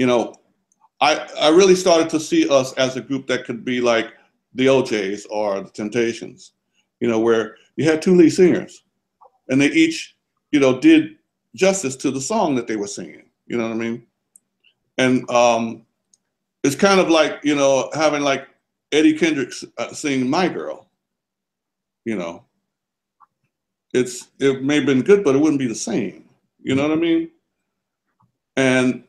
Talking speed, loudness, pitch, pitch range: 170 wpm, -18 LUFS, 135 Hz, 125-170 Hz